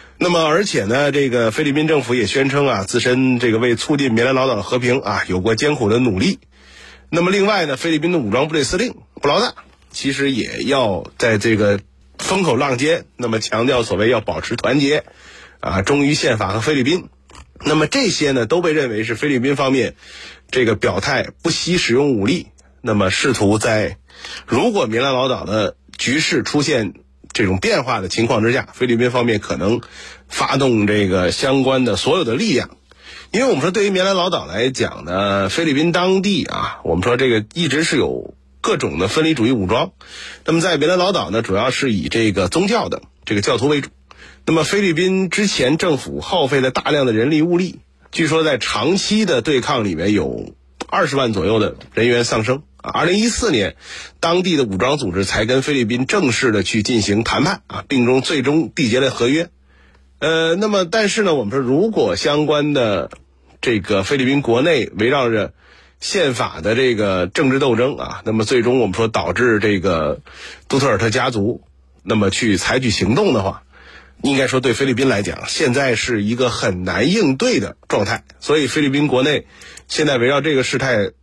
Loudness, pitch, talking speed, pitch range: -17 LUFS, 125 Hz, 285 characters per minute, 105-150 Hz